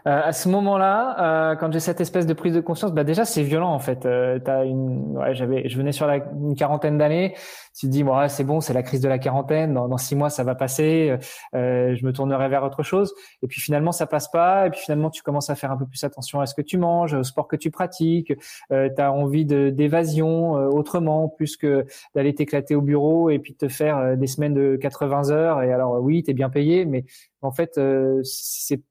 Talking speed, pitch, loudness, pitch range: 250 wpm, 145 Hz, -22 LUFS, 135-160 Hz